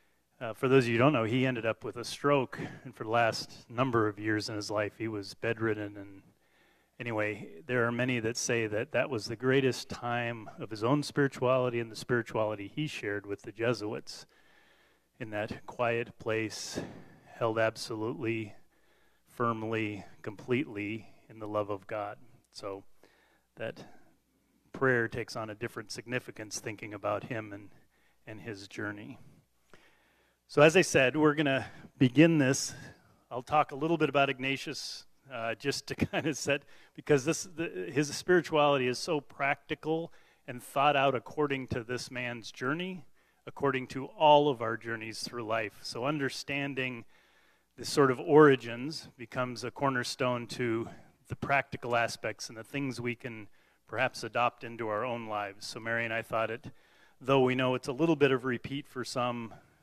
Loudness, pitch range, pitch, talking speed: -31 LUFS, 110-140 Hz, 120 Hz, 165 wpm